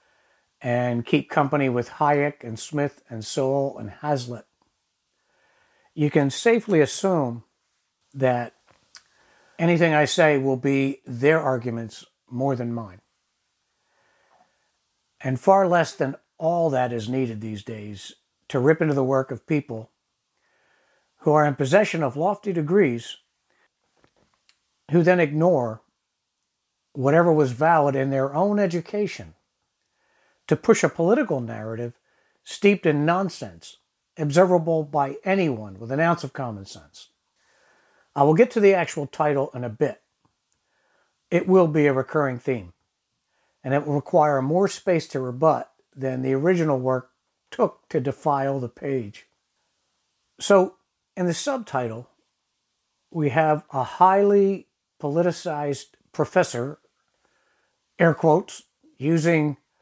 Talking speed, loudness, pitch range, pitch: 125 wpm, -22 LUFS, 130-170 Hz, 145 Hz